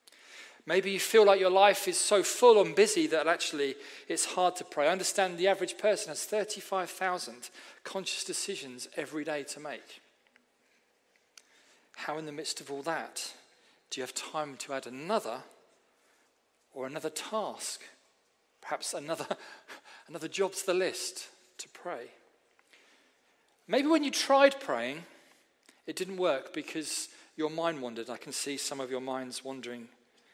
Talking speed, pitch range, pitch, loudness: 150 wpm, 140-200 Hz, 170 Hz, -30 LUFS